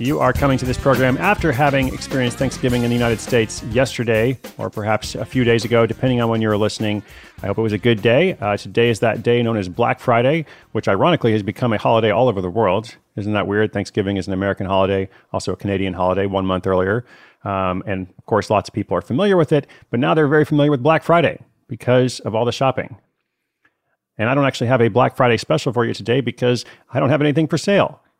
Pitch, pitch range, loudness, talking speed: 120 Hz, 105-135 Hz, -18 LUFS, 235 wpm